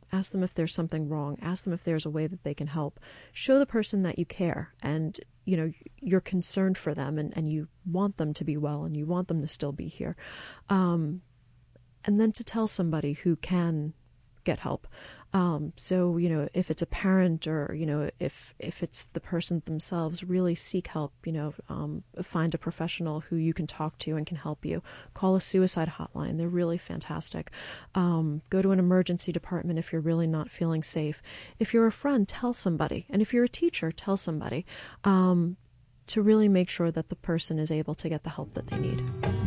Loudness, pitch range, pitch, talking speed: -29 LUFS, 155-185 Hz, 165 Hz, 210 wpm